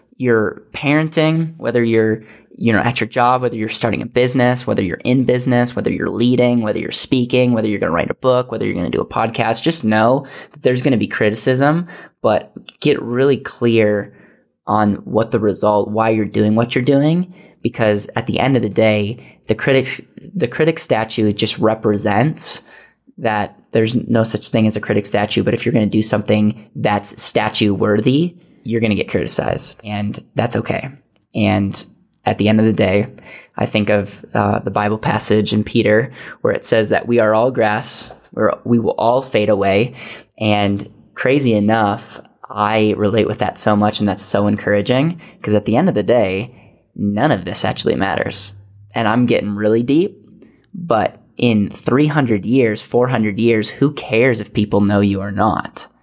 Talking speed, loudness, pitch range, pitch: 185 wpm, -16 LUFS, 105-125 Hz, 110 Hz